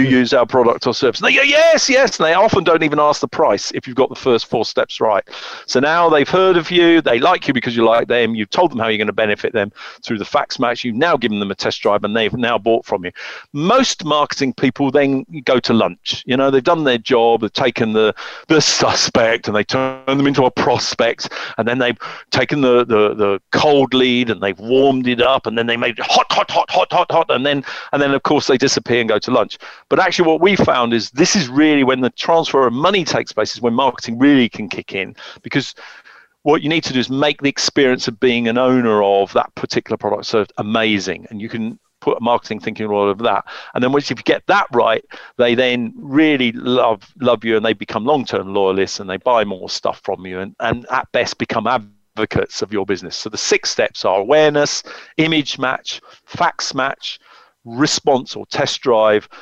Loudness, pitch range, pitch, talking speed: -16 LUFS, 115-150 Hz, 130 Hz, 230 wpm